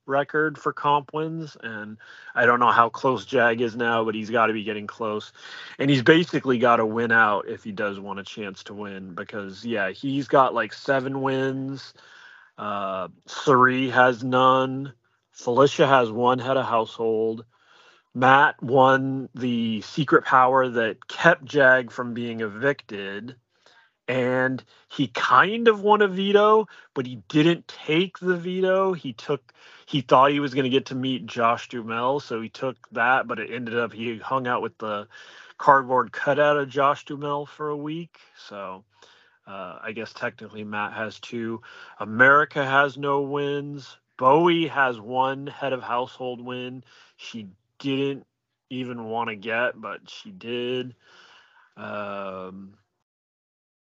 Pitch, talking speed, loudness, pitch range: 130 Hz, 155 wpm, -22 LUFS, 115-145 Hz